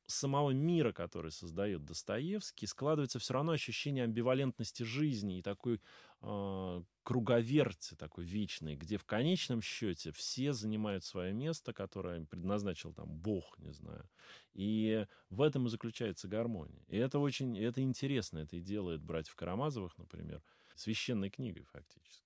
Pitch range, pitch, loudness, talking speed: 90-130 Hz, 110 Hz, -38 LUFS, 140 wpm